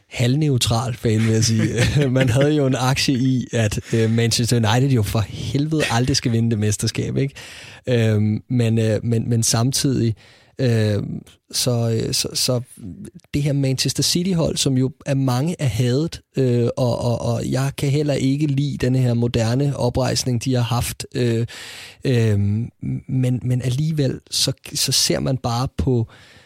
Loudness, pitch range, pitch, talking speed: -20 LUFS, 115-135 Hz, 125 Hz, 145 wpm